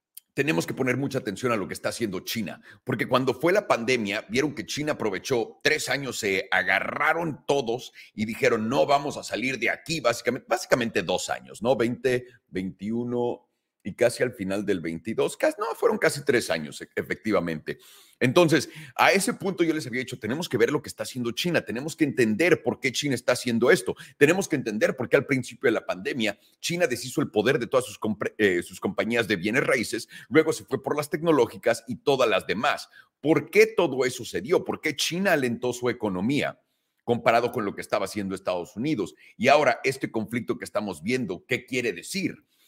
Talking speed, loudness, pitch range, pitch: 200 wpm, -25 LUFS, 115-155 Hz, 125 Hz